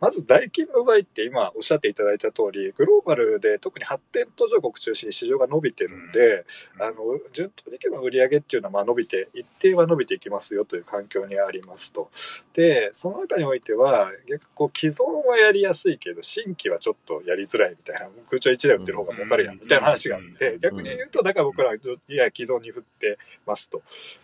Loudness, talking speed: -22 LUFS, 425 characters per minute